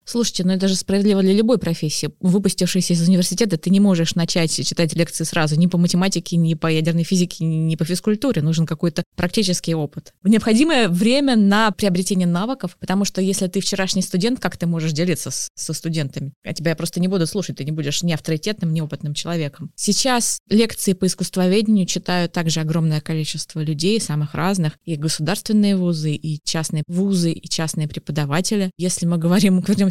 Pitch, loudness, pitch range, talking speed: 175 Hz, -19 LUFS, 160-195 Hz, 180 wpm